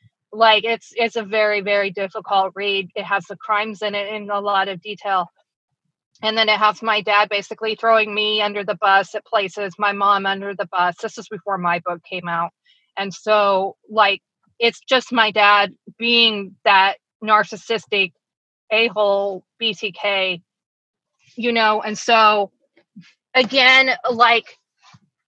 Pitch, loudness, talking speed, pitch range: 210 Hz, -18 LUFS, 150 wpm, 195-220 Hz